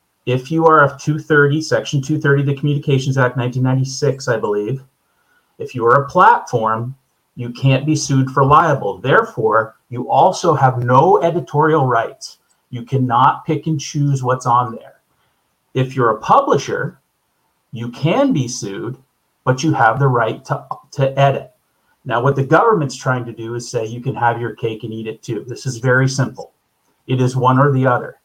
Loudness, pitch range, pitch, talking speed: -16 LUFS, 125-145 Hz, 135 Hz, 180 wpm